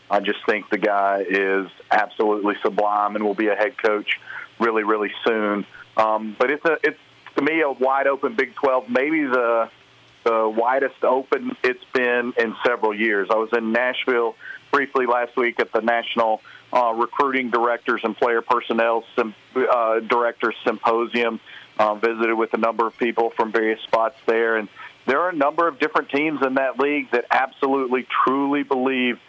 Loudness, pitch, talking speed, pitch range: -21 LUFS, 115 Hz, 175 wpm, 110-125 Hz